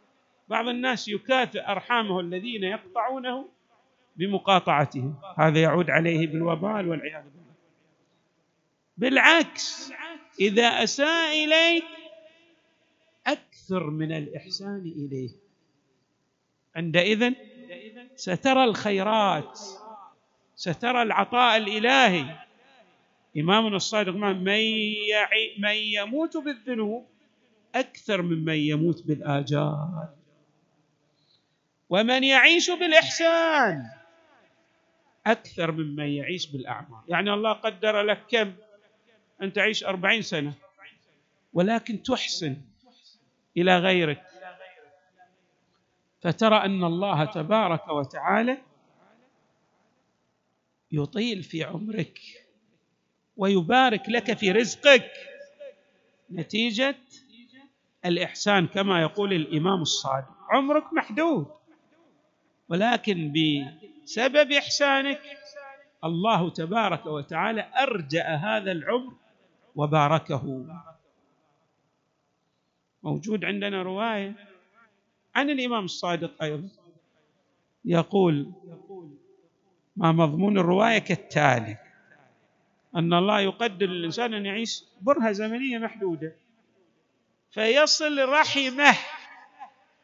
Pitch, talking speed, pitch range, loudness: 200 Hz, 75 wpm, 165-245 Hz, -24 LUFS